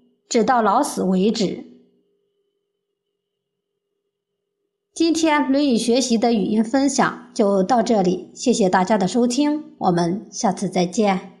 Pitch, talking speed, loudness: 240 Hz, 180 characters per minute, -19 LUFS